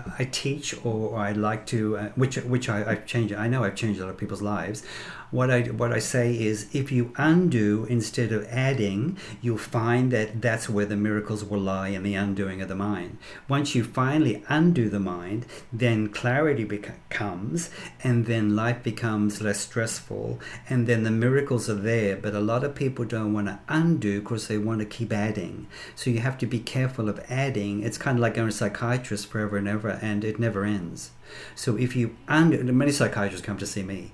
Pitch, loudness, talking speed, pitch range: 110 Hz, -26 LUFS, 205 wpm, 105-125 Hz